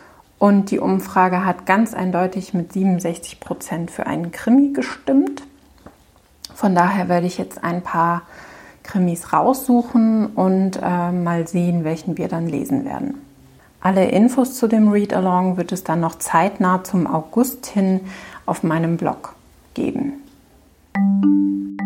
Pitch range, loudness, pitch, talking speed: 170-220 Hz, -19 LUFS, 185 Hz, 130 wpm